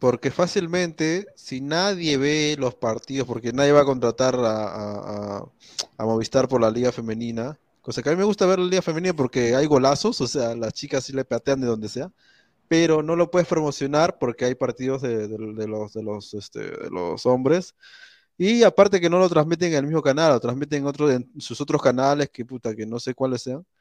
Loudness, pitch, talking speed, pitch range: -22 LUFS, 135 Hz, 220 wpm, 120-160 Hz